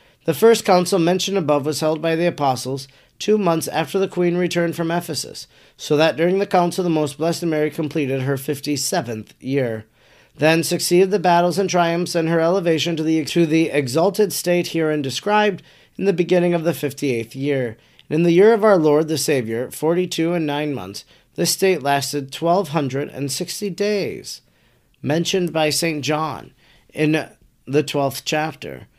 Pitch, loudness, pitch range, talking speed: 160 Hz, -19 LUFS, 145-175 Hz, 180 wpm